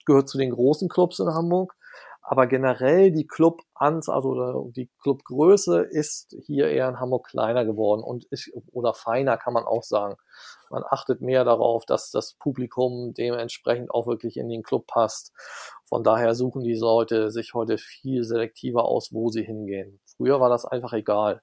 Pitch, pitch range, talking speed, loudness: 125 Hz, 115-140 Hz, 170 wpm, -24 LUFS